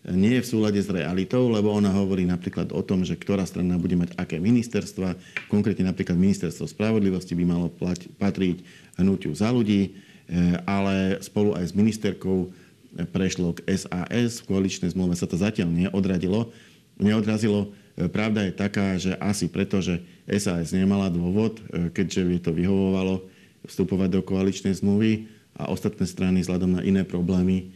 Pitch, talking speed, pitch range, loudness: 95 Hz, 155 wpm, 90-100 Hz, -25 LUFS